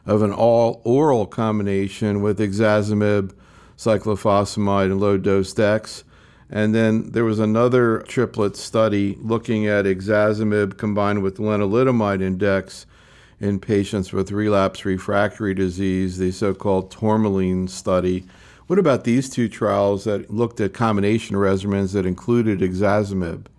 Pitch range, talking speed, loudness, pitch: 95-110 Hz, 125 wpm, -20 LUFS, 105 Hz